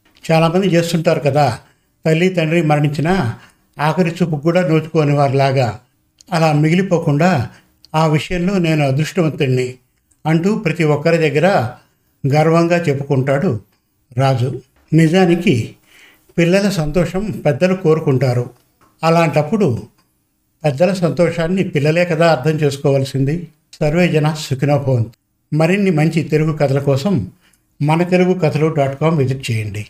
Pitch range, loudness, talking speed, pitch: 140-170 Hz, -16 LUFS, 105 wpm, 155 Hz